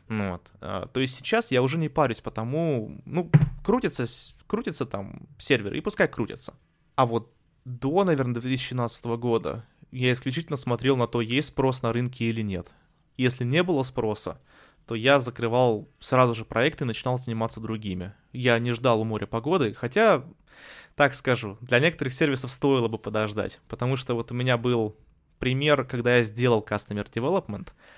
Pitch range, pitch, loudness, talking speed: 115-135 Hz, 125 Hz, -26 LUFS, 165 wpm